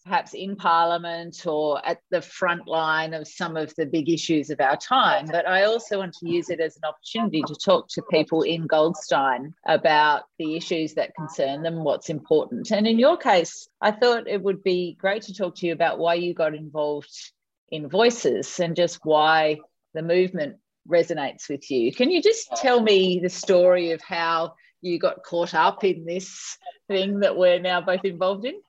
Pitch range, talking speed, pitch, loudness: 160-195 Hz, 190 wpm, 175 Hz, -23 LUFS